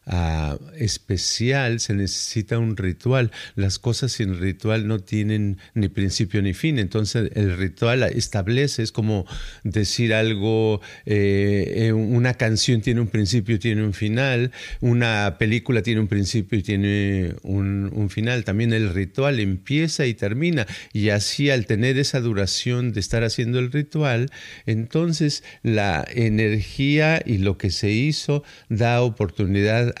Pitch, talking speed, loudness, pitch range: 110 Hz, 140 wpm, -22 LUFS, 100-120 Hz